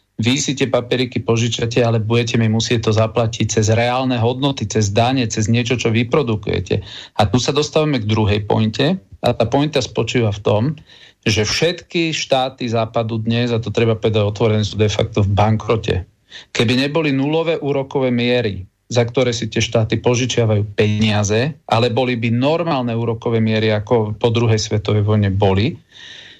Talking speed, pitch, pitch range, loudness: 165 wpm, 115 Hz, 110-130 Hz, -17 LUFS